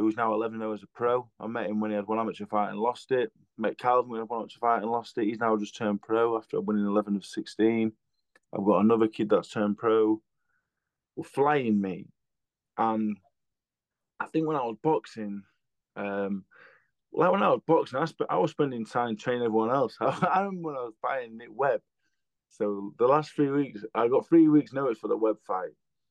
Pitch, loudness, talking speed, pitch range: 115 Hz, -28 LUFS, 215 wpm, 105-125 Hz